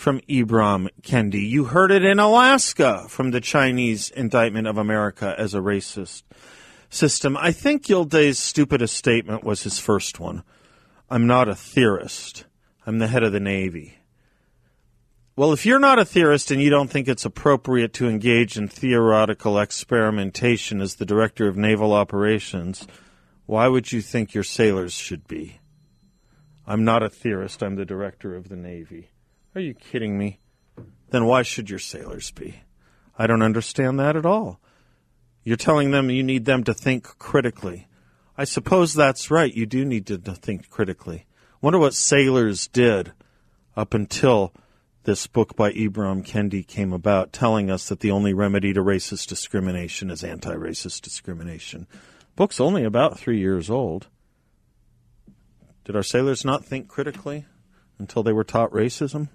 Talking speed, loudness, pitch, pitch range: 155 wpm, -21 LUFS, 115 Hz, 100-130 Hz